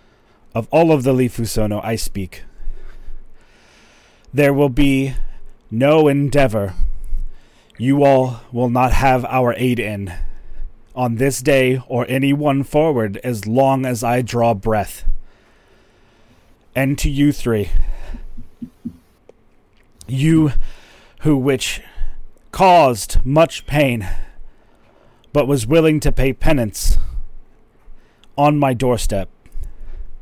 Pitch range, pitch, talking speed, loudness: 105-140 Hz, 125 Hz, 105 wpm, -17 LUFS